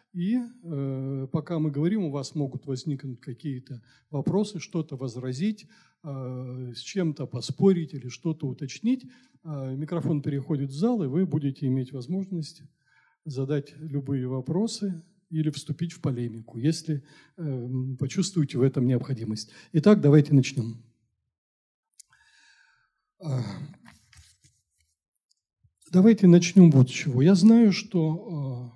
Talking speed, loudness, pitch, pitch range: 115 wpm, -25 LUFS, 145 Hz, 130-175 Hz